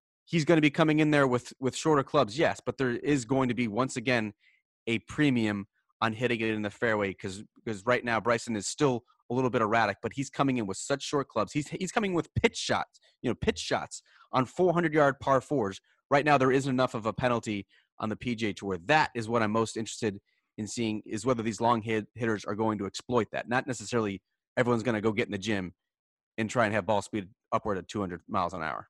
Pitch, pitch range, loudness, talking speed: 120 Hz, 110-130 Hz, -29 LUFS, 240 wpm